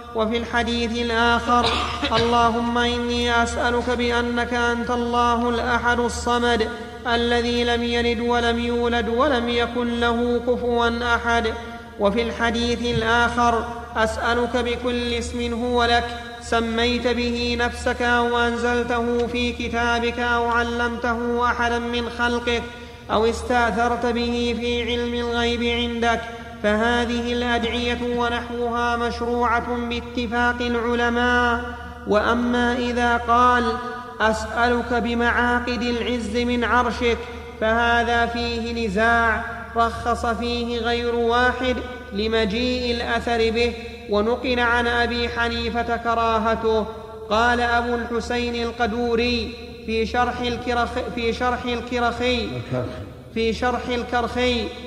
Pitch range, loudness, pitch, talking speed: 235-240 Hz, -21 LUFS, 235 Hz, 100 wpm